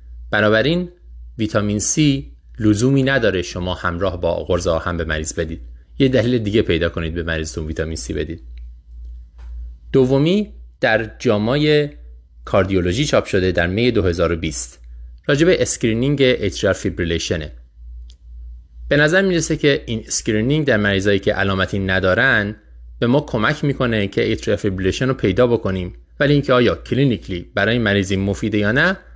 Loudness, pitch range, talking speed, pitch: -18 LUFS, 80-125 Hz, 135 wpm, 95 Hz